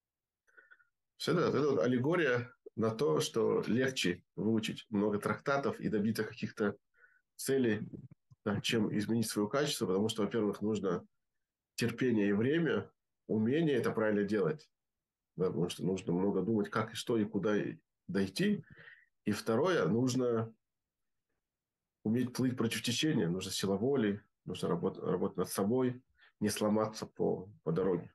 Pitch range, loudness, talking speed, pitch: 105-125 Hz, -34 LUFS, 130 wpm, 110 Hz